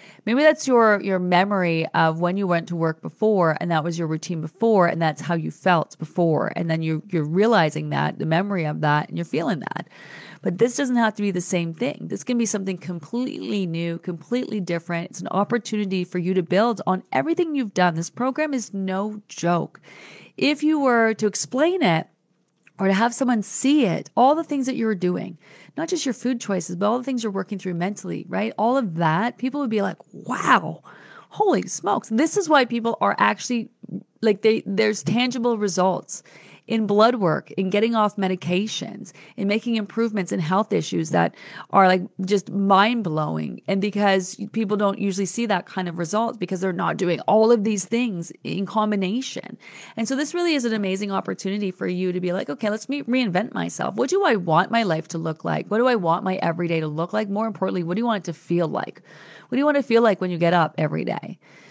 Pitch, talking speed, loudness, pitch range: 200 Hz, 220 wpm, -22 LUFS, 175-230 Hz